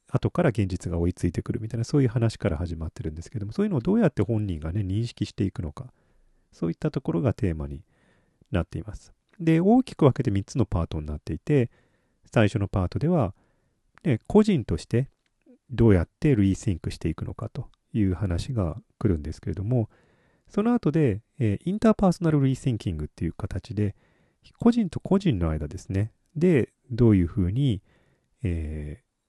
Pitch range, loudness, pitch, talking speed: 95-140 Hz, -26 LUFS, 110 Hz, 380 characters per minute